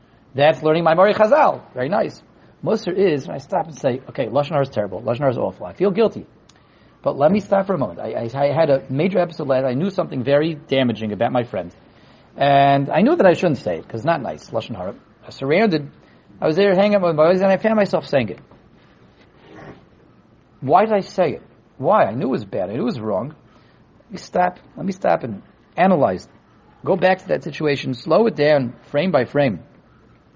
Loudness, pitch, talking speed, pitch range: -19 LUFS, 155 Hz, 220 wpm, 135-190 Hz